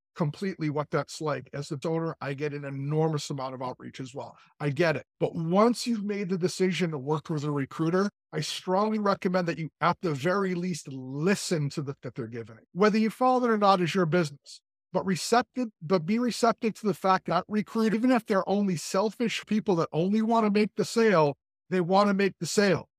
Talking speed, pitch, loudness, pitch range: 220 wpm, 180 Hz, -27 LUFS, 150-205 Hz